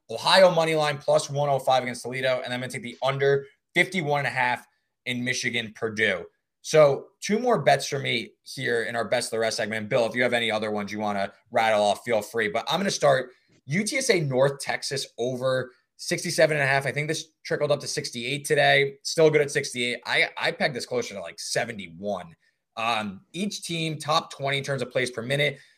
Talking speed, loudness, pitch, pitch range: 210 wpm, -25 LUFS, 140 Hz, 120-155 Hz